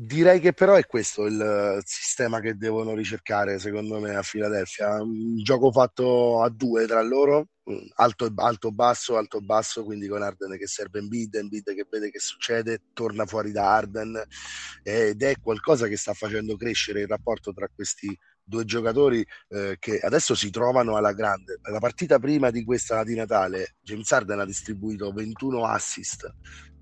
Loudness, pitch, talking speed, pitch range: -25 LUFS, 110 Hz, 165 wpm, 105-120 Hz